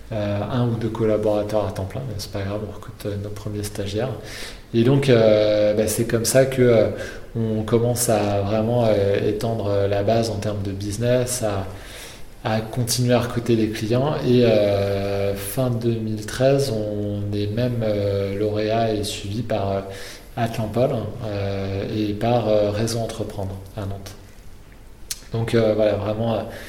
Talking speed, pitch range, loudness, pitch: 165 wpm, 105-115 Hz, -22 LUFS, 110 Hz